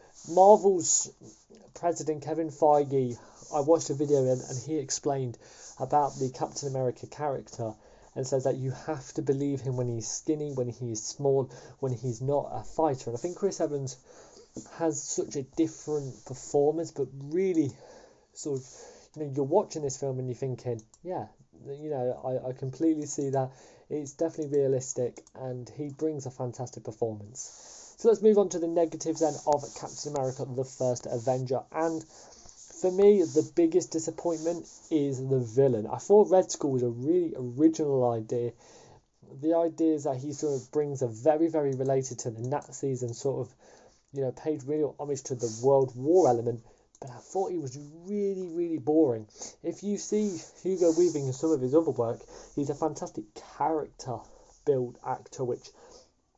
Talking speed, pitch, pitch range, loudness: 170 wpm, 145 Hz, 130-160 Hz, -29 LUFS